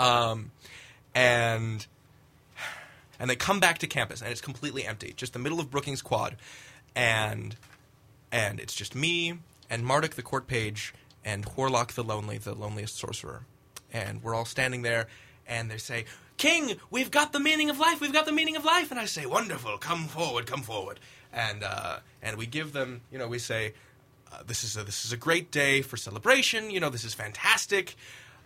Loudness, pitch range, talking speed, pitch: -28 LUFS, 115-145 Hz, 190 wpm, 125 Hz